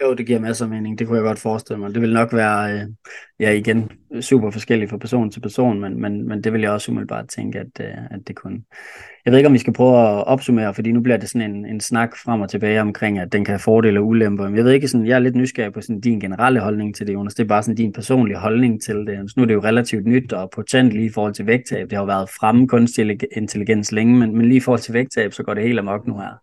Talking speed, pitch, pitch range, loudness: 280 wpm, 110 Hz, 105-120 Hz, -18 LUFS